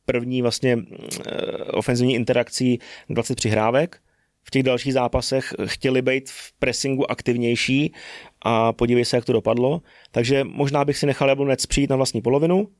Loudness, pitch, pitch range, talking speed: -22 LUFS, 130 Hz, 120-135 Hz, 150 wpm